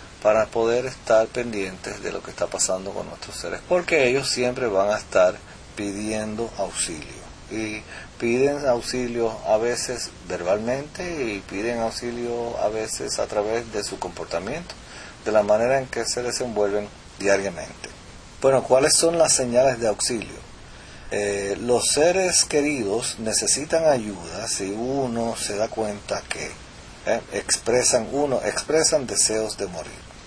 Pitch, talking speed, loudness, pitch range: 115 Hz, 140 wpm, -23 LUFS, 105-130 Hz